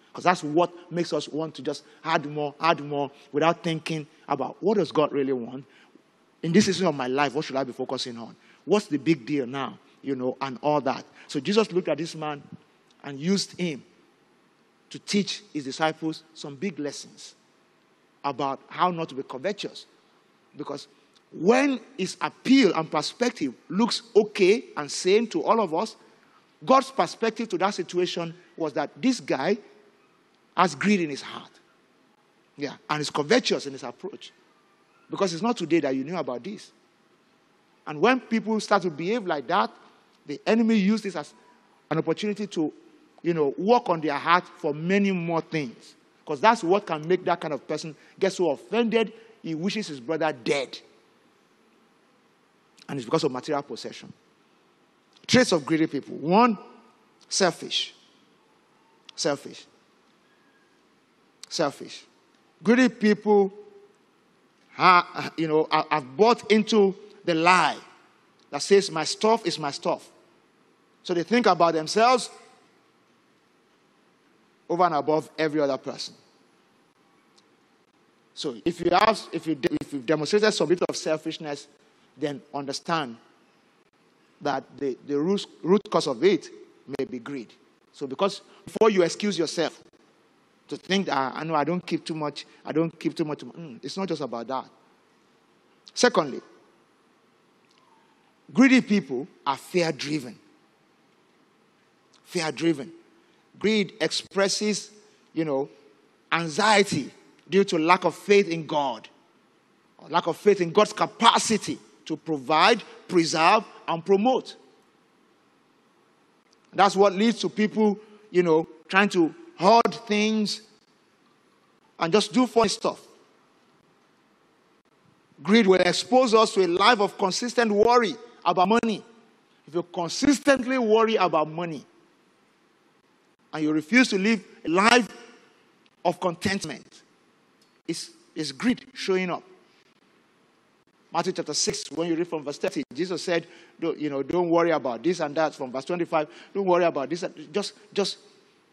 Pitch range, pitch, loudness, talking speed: 155-210 Hz, 175 Hz, -25 LUFS, 145 wpm